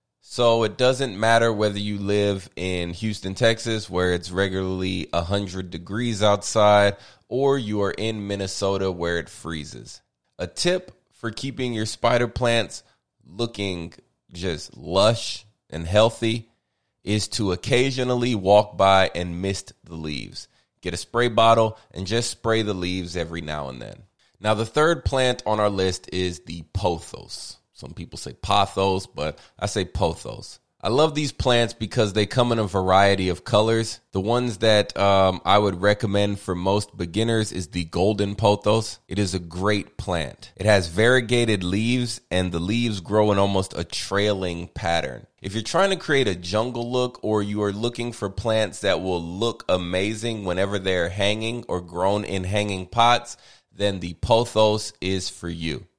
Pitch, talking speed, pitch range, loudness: 105 Hz, 165 wpm, 95-115 Hz, -23 LUFS